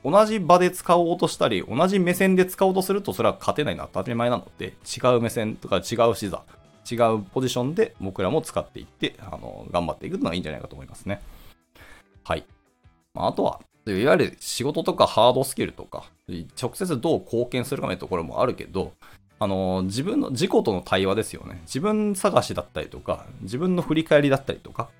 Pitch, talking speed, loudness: 115 Hz, 405 characters per minute, -24 LUFS